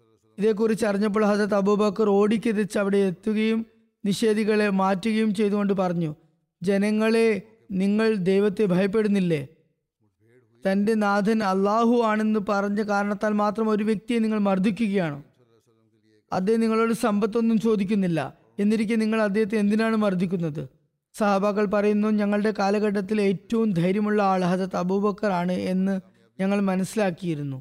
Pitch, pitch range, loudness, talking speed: 205 Hz, 190-220 Hz, -23 LUFS, 105 wpm